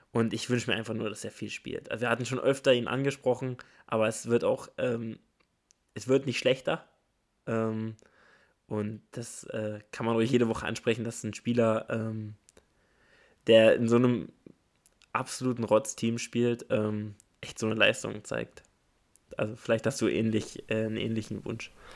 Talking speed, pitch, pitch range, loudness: 170 wpm, 115 Hz, 110-120 Hz, -29 LUFS